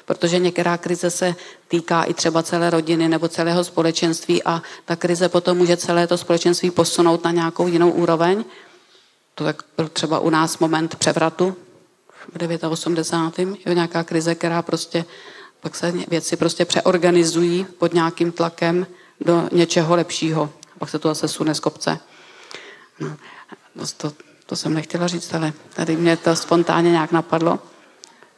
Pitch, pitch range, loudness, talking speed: 170 Hz, 165-175 Hz, -20 LUFS, 150 wpm